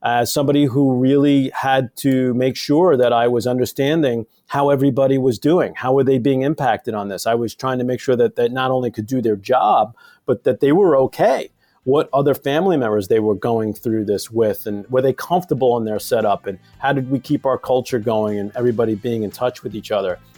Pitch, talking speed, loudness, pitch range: 130 Hz, 220 wpm, -18 LUFS, 115-140 Hz